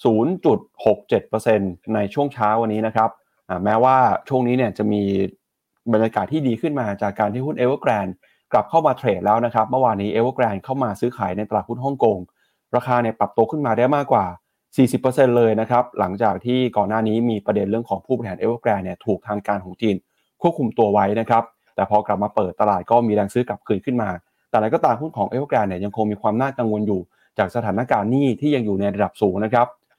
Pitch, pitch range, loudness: 110 Hz, 105-125 Hz, -20 LUFS